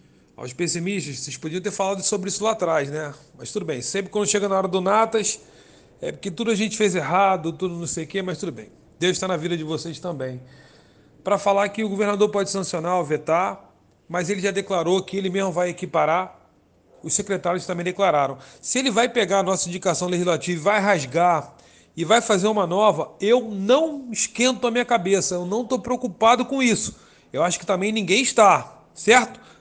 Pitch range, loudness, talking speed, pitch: 175-210 Hz, -22 LUFS, 200 wpm, 190 Hz